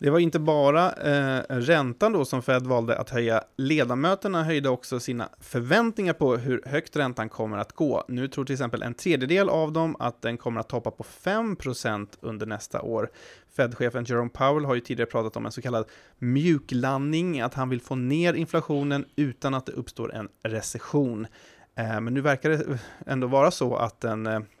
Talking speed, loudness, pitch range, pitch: 190 wpm, -26 LUFS, 115-150 Hz, 130 Hz